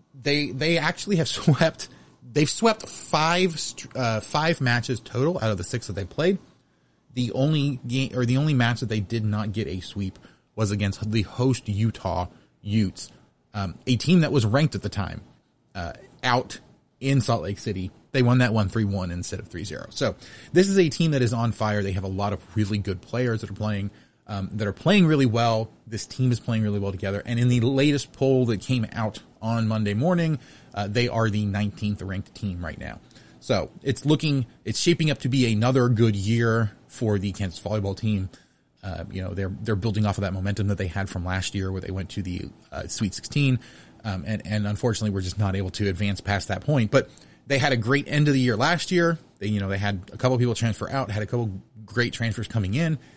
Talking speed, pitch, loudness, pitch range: 225 wpm, 110 Hz, -25 LUFS, 100-130 Hz